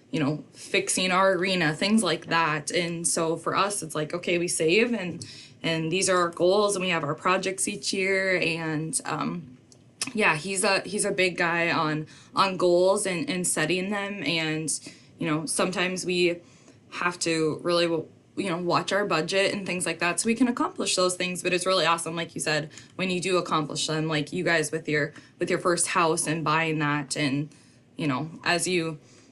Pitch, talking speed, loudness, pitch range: 170 Hz, 200 wpm, -25 LUFS, 155-185 Hz